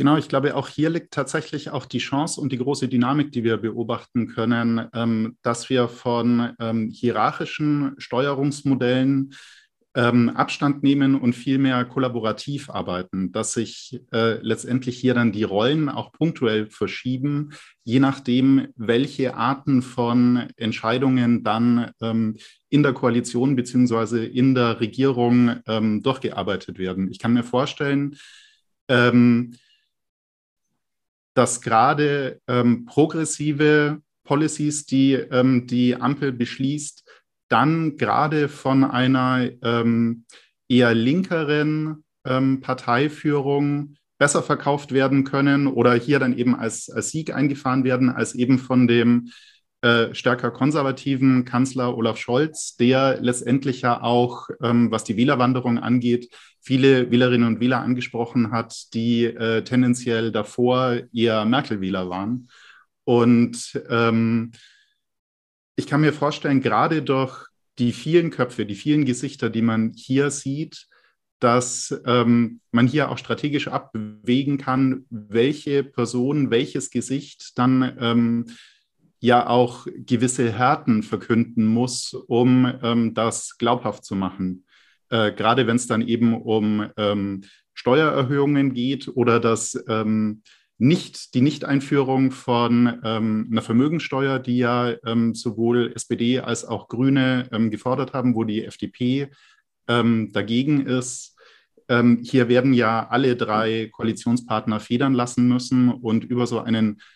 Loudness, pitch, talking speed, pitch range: -21 LUFS, 125 Hz, 125 wpm, 115-135 Hz